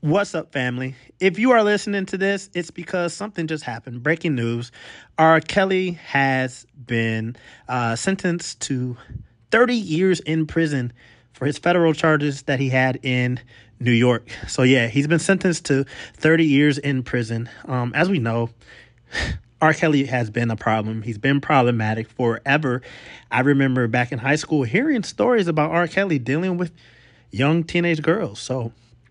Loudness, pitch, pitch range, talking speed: -21 LUFS, 140 Hz, 120-165 Hz, 160 wpm